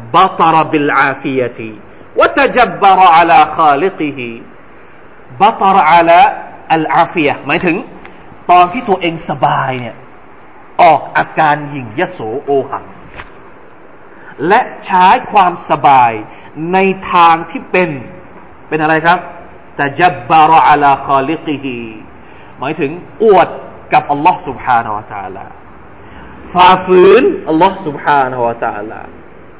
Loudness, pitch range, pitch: -10 LUFS, 135-185 Hz, 160 Hz